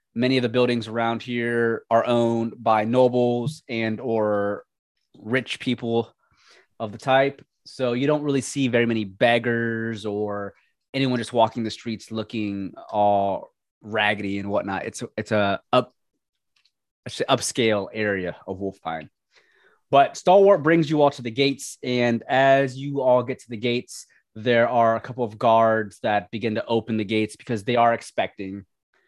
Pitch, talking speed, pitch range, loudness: 115 Hz, 165 wpm, 110-125 Hz, -23 LUFS